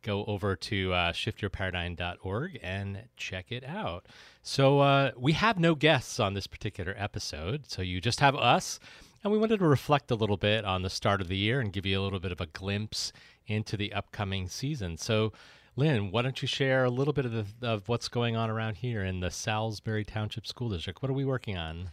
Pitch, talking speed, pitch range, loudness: 110 Hz, 215 wpm, 95-130 Hz, -30 LUFS